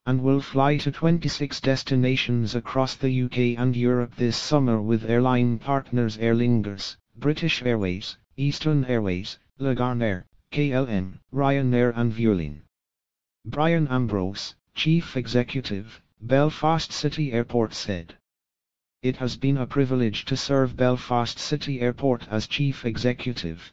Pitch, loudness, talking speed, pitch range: 125 Hz, -24 LUFS, 125 wpm, 110-135 Hz